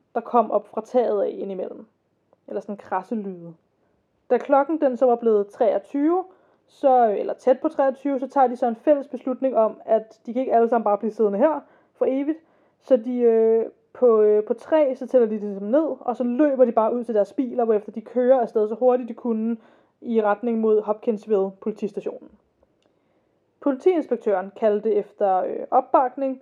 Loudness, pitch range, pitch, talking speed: -22 LUFS, 215-265 Hz, 240 Hz, 185 wpm